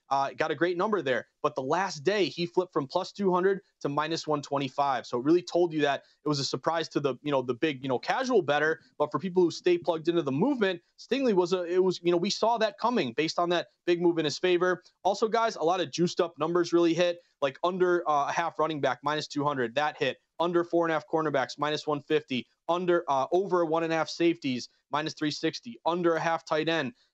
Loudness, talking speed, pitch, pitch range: -28 LUFS, 245 wpm, 165 Hz, 150-180 Hz